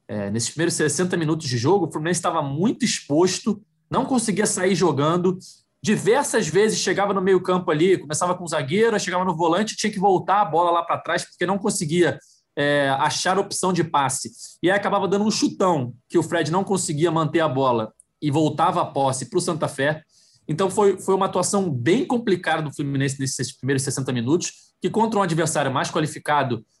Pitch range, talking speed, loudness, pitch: 150-195 Hz, 195 wpm, -22 LUFS, 175 Hz